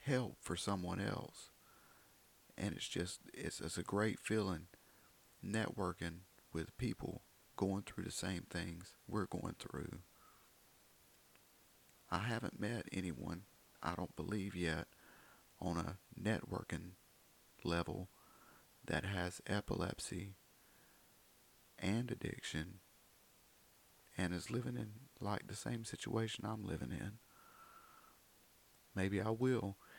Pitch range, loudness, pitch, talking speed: 90-110 Hz, -43 LUFS, 95 Hz, 110 wpm